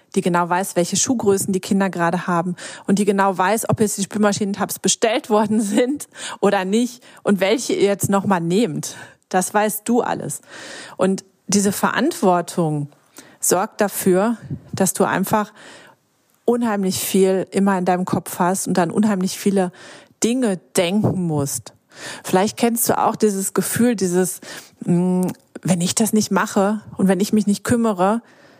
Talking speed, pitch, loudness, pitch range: 150 wpm, 195 Hz, -19 LUFS, 185-215 Hz